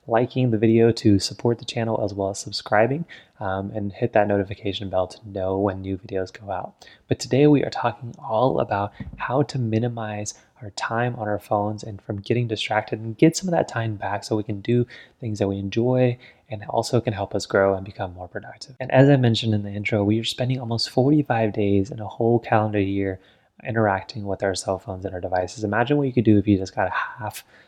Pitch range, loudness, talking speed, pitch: 100-120 Hz, -23 LUFS, 230 wpm, 110 Hz